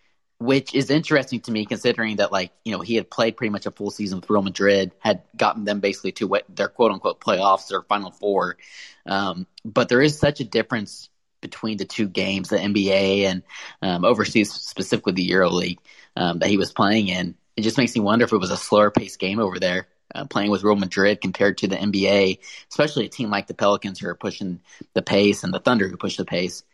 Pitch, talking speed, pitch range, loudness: 100 Hz, 220 wpm, 95-110 Hz, -22 LUFS